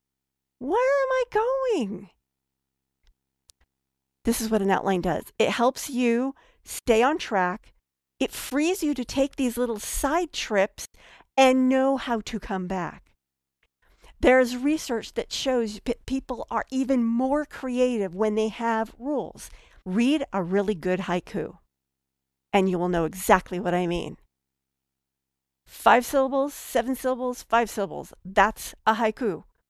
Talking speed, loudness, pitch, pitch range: 135 wpm, -25 LUFS, 220 Hz, 165-255 Hz